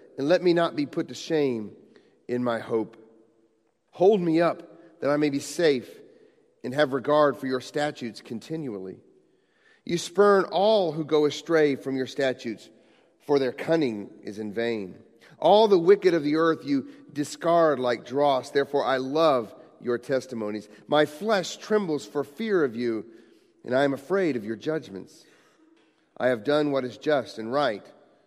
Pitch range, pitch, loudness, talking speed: 125-170 Hz, 145 Hz, -25 LUFS, 165 wpm